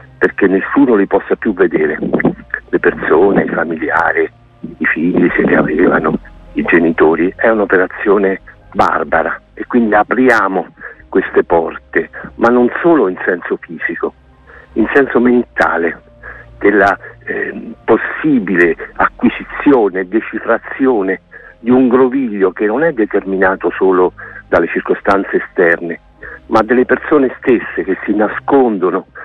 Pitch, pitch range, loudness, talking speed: 120 Hz, 95-140 Hz, -13 LUFS, 115 wpm